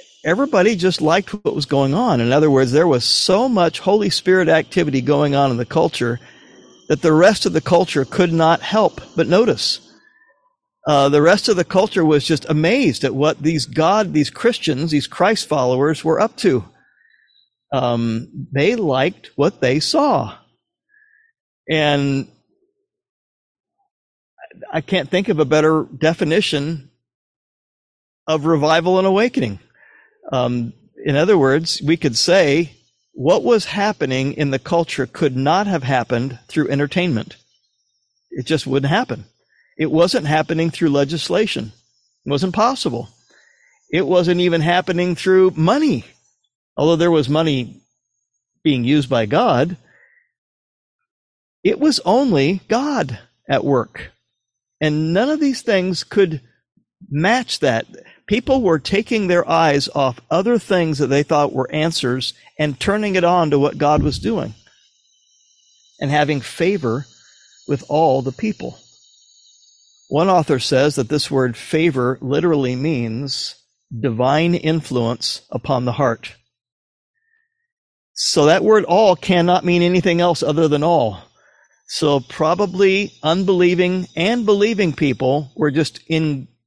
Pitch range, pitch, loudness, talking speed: 135-190 Hz, 160 Hz, -17 LUFS, 135 wpm